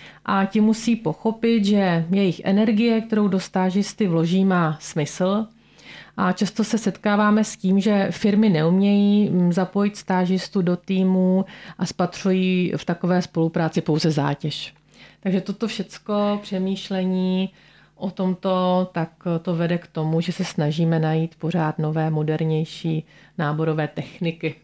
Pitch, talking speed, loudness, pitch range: 185 Hz, 130 wpm, -22 LUFS, 165-200 Hz